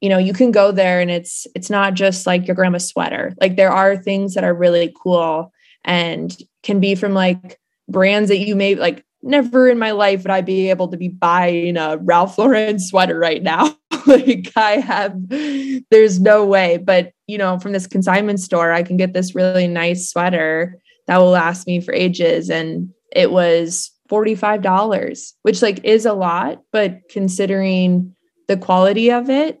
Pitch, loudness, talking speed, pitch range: 190 Hz, -16 LUFS, 185 wpm, 180-210 Hz